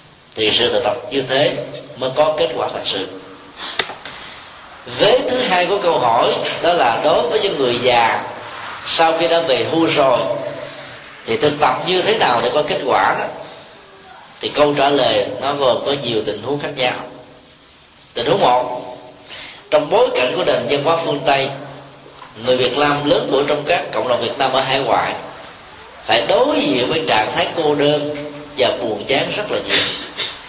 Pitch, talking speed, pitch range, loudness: 145 Hz, 185 wpm, 125-165 Hz, -16 LUFS